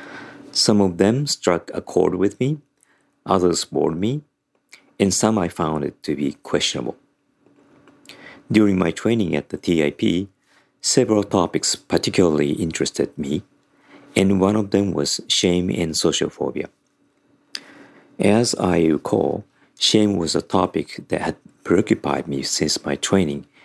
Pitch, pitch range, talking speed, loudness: 100 Hz, 85-110 Hz, 130 wpm, -20 LUFS